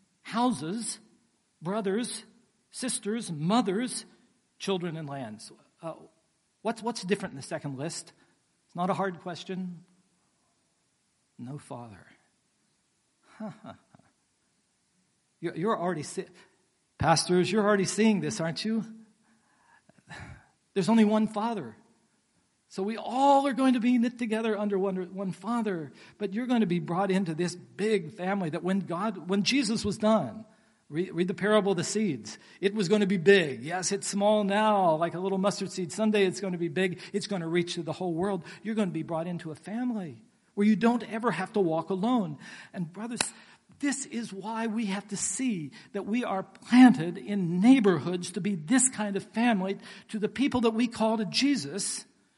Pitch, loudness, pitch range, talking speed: 200 Hz, -28 LUFS, 180-220 Hz, 170 wpm